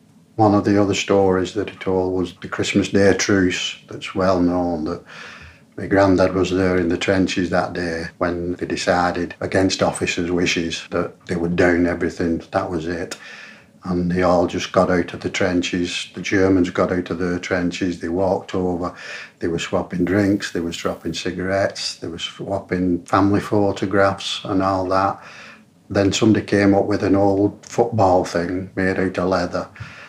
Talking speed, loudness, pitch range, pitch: 175 wpm, -20 LUFS, 90-100 Hz, 95 Hz